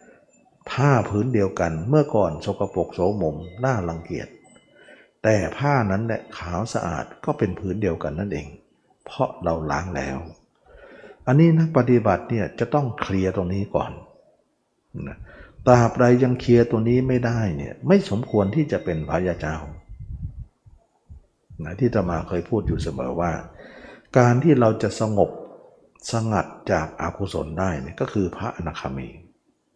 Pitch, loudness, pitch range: 105 Hz, -22 LUFS, 85-120 Hz